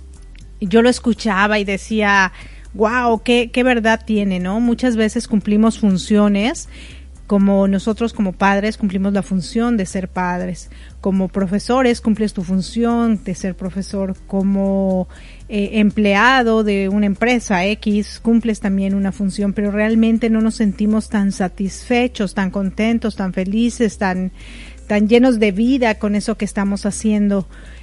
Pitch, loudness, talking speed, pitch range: 205 Hz, -17 LUFS, 140 wpm, 195-225 Hz